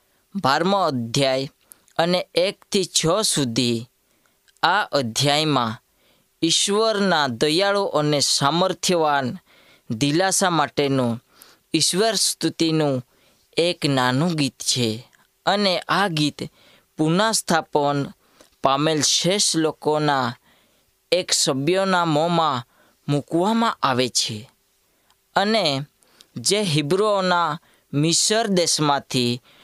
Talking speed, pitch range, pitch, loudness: 75 wpm, 135-180 Hz, 150 Hz, -20 LUFS